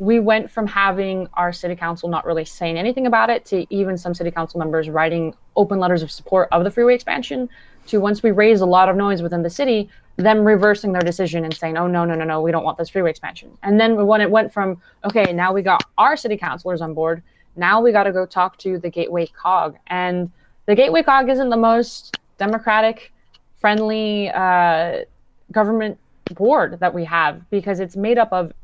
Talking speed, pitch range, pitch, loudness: 210 wpm, 170-215 Hz, 190 Hz, -18 LUFS